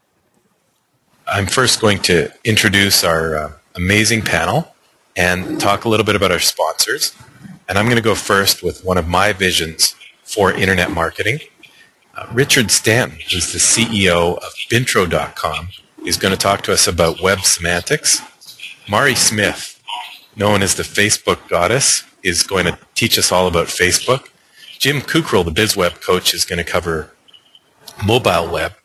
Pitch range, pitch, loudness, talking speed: 85-100 Hz, 90 Hz, -15 LUFS, 155 wpm